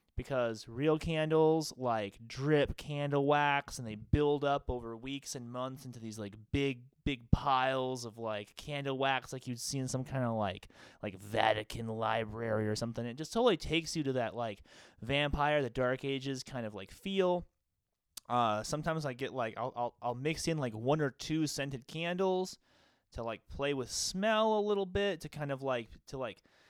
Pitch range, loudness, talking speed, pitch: 115-150 Hz, -34 LUFS, 190 wpm, 130 Hz